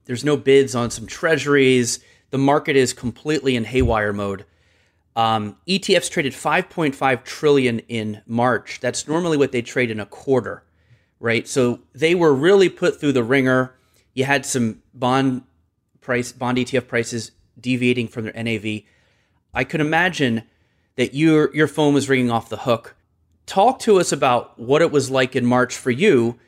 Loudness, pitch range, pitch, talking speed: -19 LUFS, 115-140 Hz, 125 Hz, 165 wpm